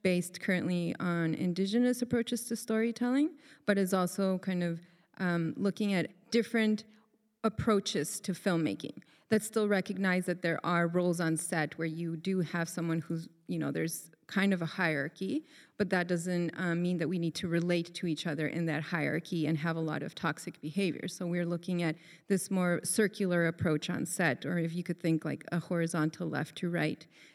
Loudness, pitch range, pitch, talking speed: -33 LUFS, 165-195 Hz, 175 Hz, 185 wpm